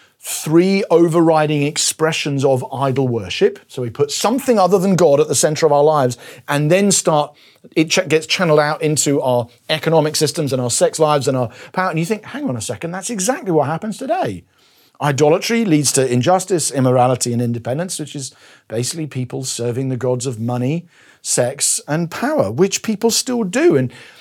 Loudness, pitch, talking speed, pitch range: -17 LUFS, 155 Hz, 185 wpm, 135-185 Hz